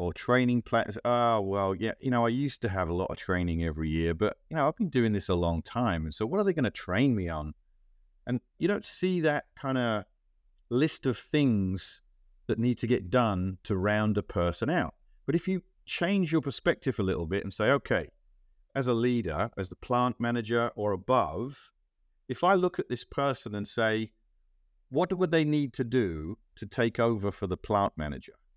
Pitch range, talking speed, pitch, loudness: 90-130 Hz, 210 wpm, 110 Hz, -29 LUFS